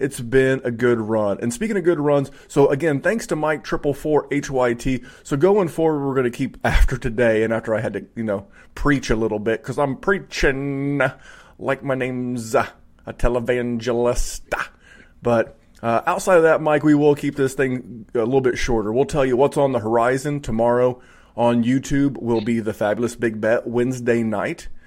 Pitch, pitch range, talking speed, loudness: 130 Hz, 120-145 Hz, 190 wpm, -20 LUFS